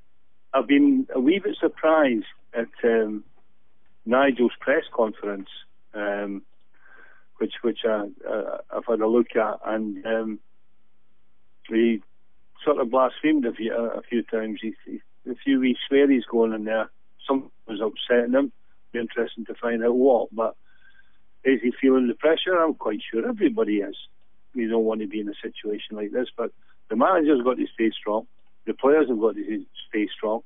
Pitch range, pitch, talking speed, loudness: 110-140 Hz, 120 Hz, 165 wpm, -24 LUFS